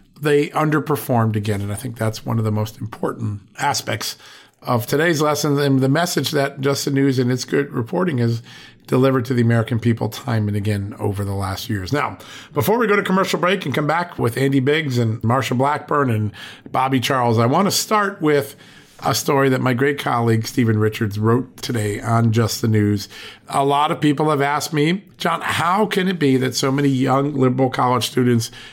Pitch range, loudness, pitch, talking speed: 115-145 Hz, -19 LUFS, 130 Hz, 205 wpm